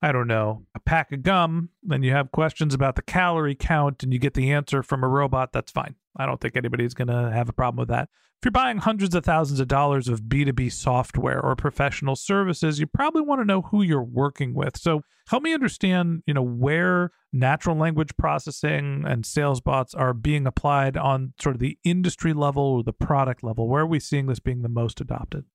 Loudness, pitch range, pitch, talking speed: -24 LUFS, 130-165 Hz, 140 Hz, 220 wpm